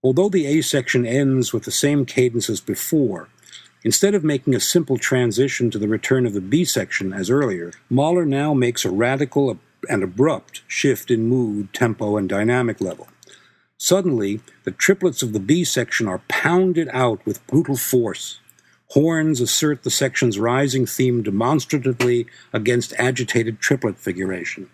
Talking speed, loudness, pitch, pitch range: 155 wpm, -20 LUFS, 125 Hz, 115-145 Hz